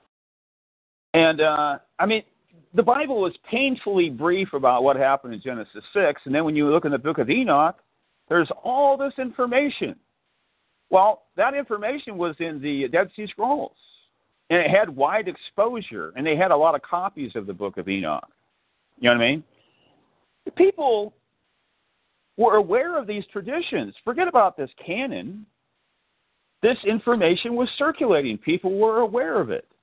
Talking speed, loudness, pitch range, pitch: 160 wpm, -22 LUFS, 155-265 Hz, 210 Hz